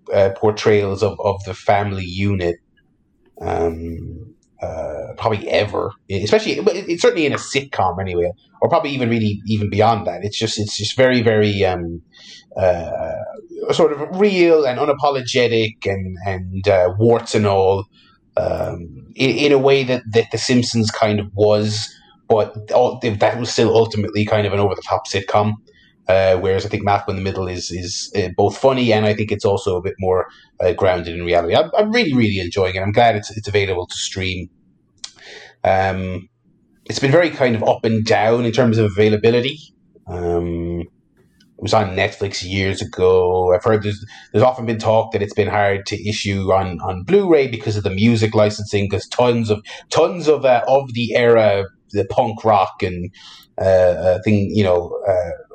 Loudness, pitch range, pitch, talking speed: -18 LUFS, 95-120 Hz, 105 Hz, 180 wpm